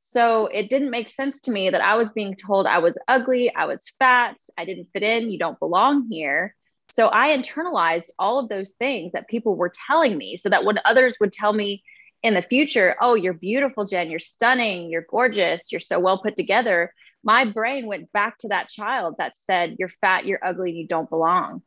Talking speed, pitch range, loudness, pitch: 215 wpm, 185-245 Hz, -21 LUFS, 210 Hz